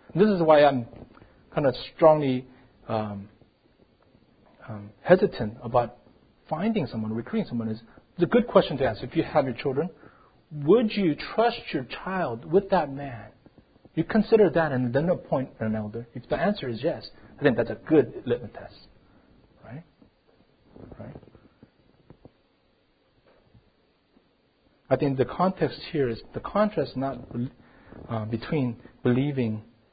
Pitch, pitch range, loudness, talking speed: 135 Hz, 115-170 Hz, -26 LUFS, 135 wpm